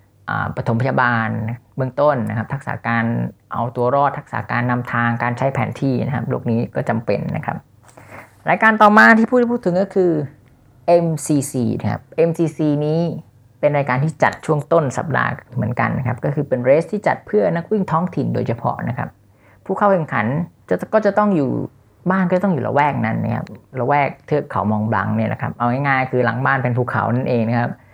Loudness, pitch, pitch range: -18 LUFS, 135 Hz, 120-165 Hz